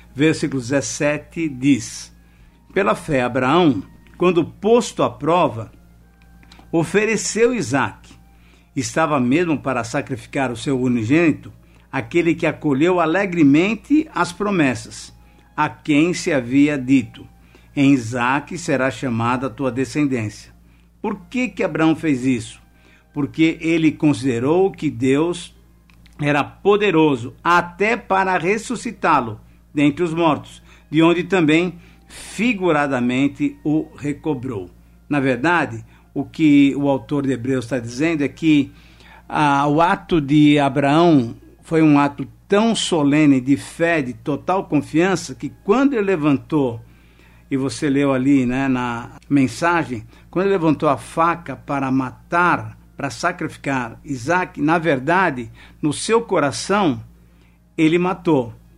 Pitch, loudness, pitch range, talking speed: 145 Hz, -19 LUFS, 130-170 Hz, 120 wpm